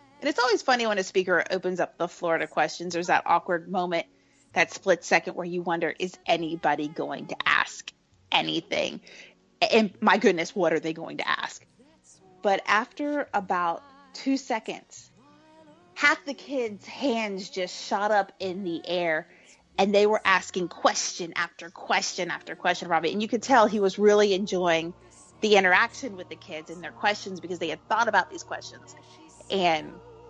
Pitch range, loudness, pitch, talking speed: 170-225 Hz, -26 LUFS, 190 Hz, 170 wpm